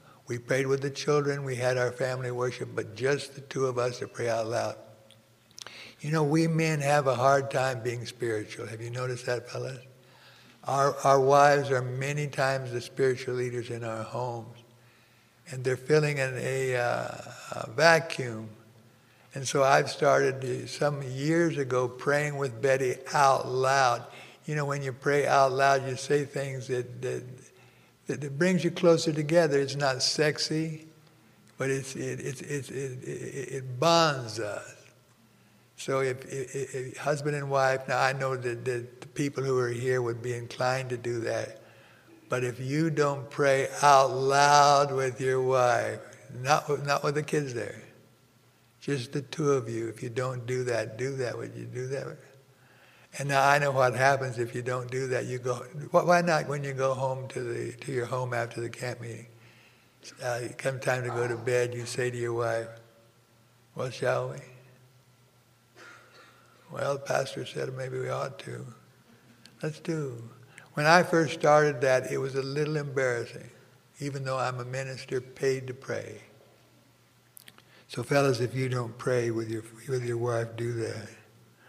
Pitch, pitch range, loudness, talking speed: 130 Hz, 125-140 Hz, -28 LUFS, 170 wpm